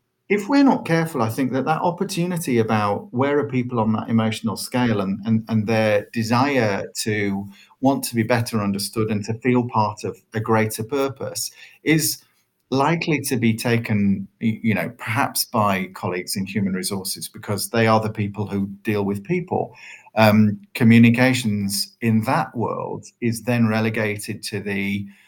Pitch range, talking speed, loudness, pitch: 105-125 Hz, 160 wpm, -21 LUFS, 110 Hz